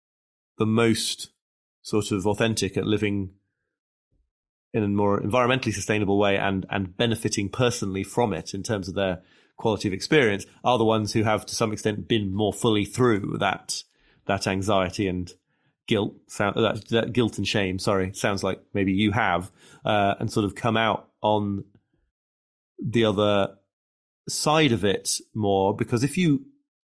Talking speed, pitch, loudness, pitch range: 155 wpm, 105 Hz, -24 LUFS, 95-115 Hz